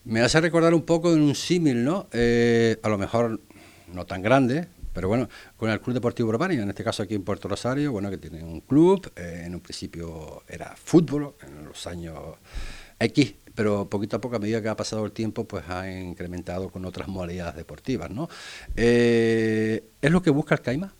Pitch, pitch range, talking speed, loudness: 110 Hz, 95-125 Hz, 205 wpm, -24 LUFS